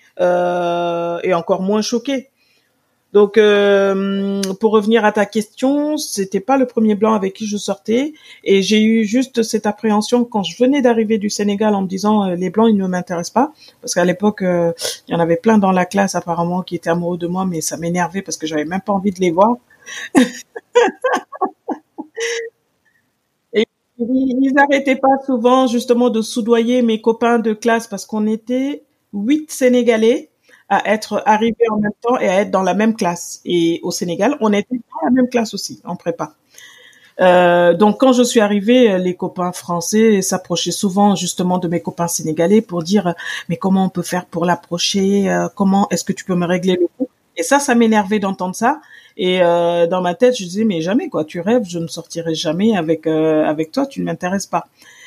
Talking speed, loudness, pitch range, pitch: 195 wpm, -16 LUFS, 180-235 Hz, 205 Hz